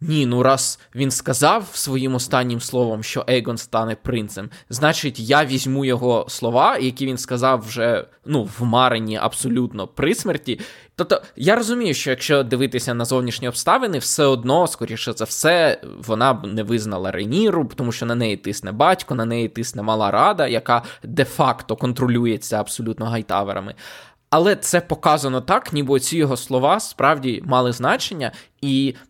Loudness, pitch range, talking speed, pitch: -20 LUFS, 115-135 Hz, 155 wpm, 125 Hz